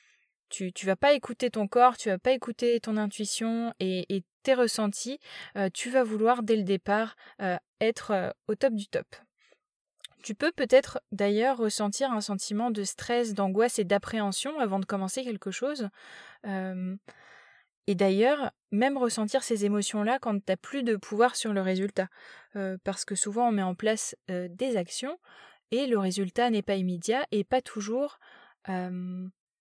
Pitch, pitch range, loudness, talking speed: 215 Hz, 195-245 Hz, -29 LUFS, 175 wpm